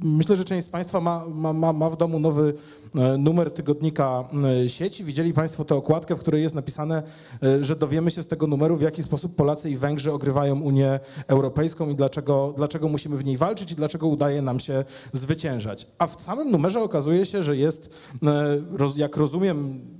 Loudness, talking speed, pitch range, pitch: -24 LUFS, 180 wpm, 140-165 Hz, 155 Hz